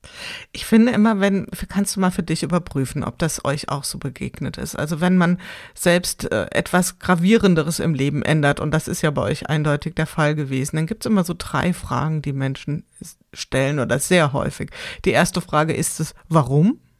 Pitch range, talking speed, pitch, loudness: 145-180 Hz, 190 wpm, 160 Hz, -20 LUFS